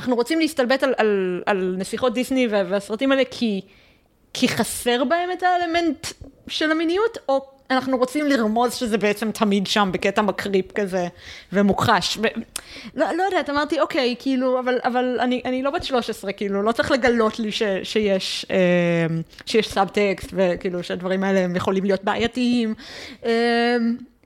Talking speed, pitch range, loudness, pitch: 140 wpm, 200-260 Hz, -21 LUFS, 230 Hz